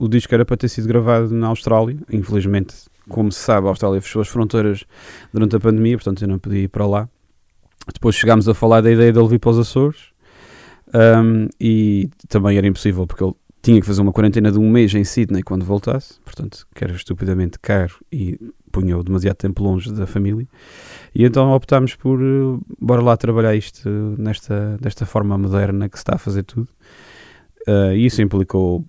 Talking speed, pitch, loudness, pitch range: 195 wpm, 105 Hz, -17 LUFS, 100-115 Hz